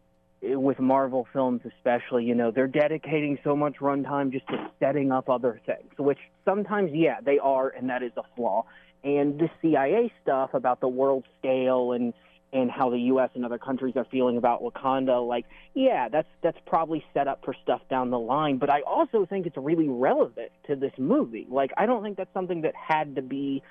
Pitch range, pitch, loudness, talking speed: 125-155 Hz, 135 Hz, -26 LUFS, 200 wpm